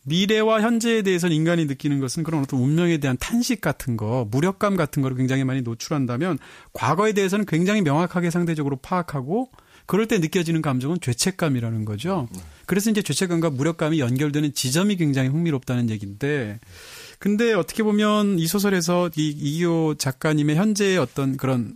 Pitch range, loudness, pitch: 135-190 Hz, -22 LUFS, 160 Hz